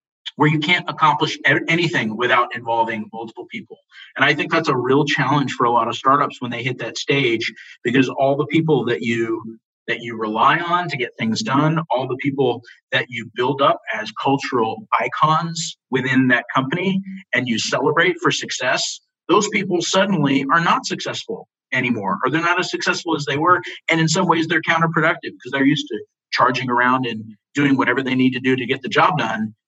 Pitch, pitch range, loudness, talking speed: 140 Hz, 120-170 Hz, -19 LUFS, 195 wpm